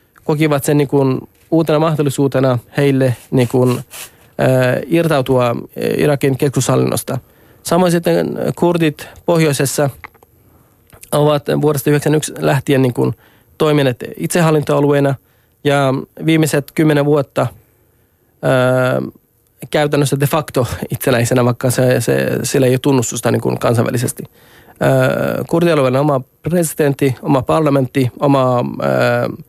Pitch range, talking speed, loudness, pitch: 125-150 Hz, 100 wpm, -15 LUFS, 140 Hz